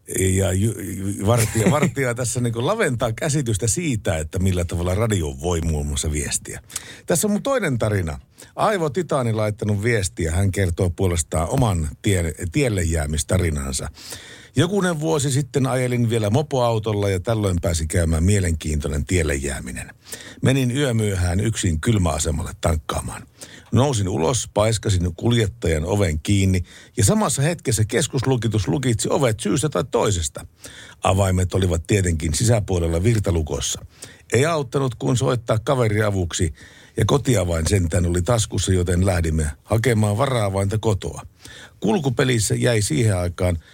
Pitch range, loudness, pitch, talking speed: 90-120 Hz, -21 LUFS, 105 Hz, 125 wpm